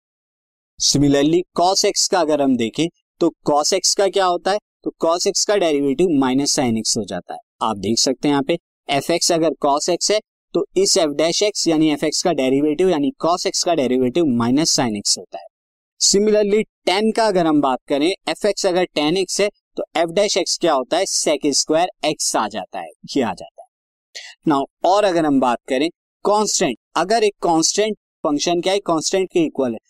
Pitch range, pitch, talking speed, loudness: 145-205 Hz, 170 Hz, 205 wpm, -18 LUFS